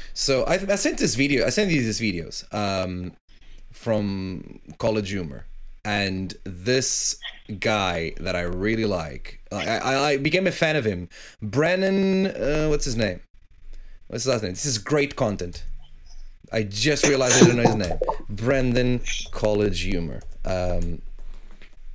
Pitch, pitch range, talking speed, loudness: 105 Hz, 90-135 Hz, 150 wpm, -23 LUFS